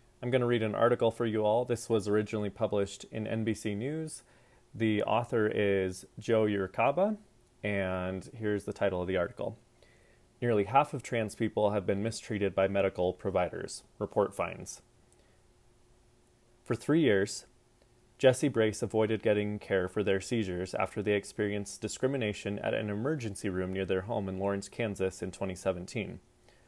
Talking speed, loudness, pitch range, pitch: 155 wpm, -32 LUFS, 100-120 Hz, 110 Hz